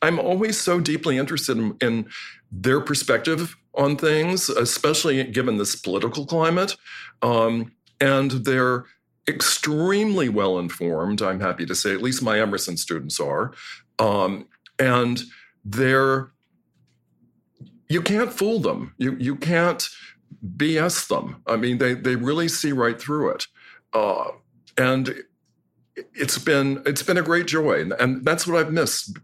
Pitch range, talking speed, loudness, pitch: 125-165 Hz, 140 wpm, -22 LUFS, 140 Hz